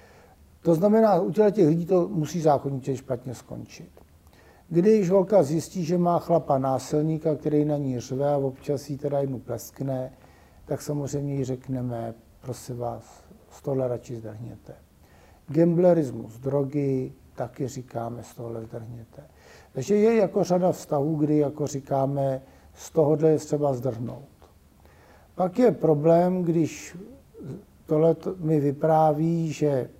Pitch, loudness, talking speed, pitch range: 140 Hz, -24 LUFS, 130 wpm, 120-160 Hz